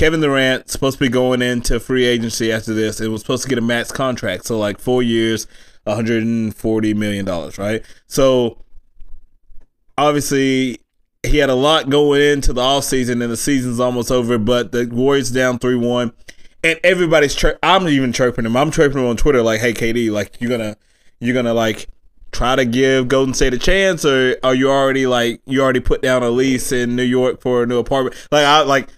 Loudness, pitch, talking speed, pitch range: -16 LUFS, 125 Hz, 205 wpm, 115-135 Hz